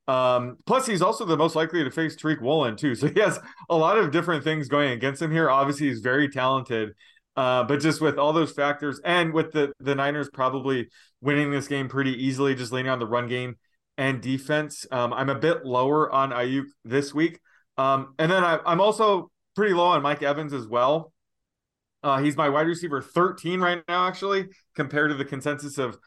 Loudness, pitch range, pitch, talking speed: -24 LUFS, 135-160 Hz, 145 Hz, 205 wpm